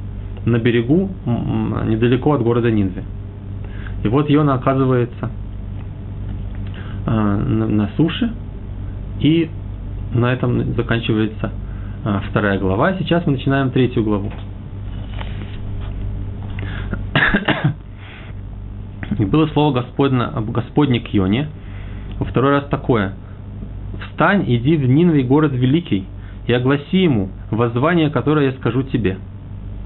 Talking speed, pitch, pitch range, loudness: 95 wpm, 105 Hz, 100-130 Hz, -18 LUFS